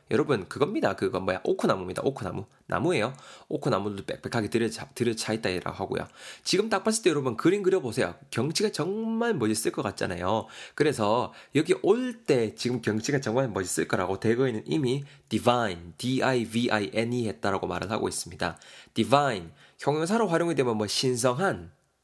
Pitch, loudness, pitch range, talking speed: 125 Hz, -27 LUFS, 110-145 Hz, 390 characters per minute